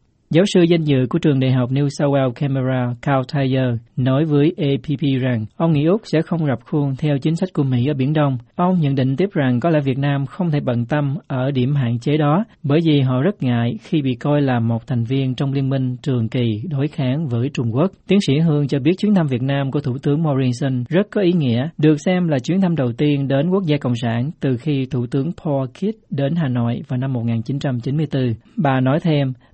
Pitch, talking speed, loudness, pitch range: 140 Hz, 240 wpm, -19 LUFS, 130-155 Hz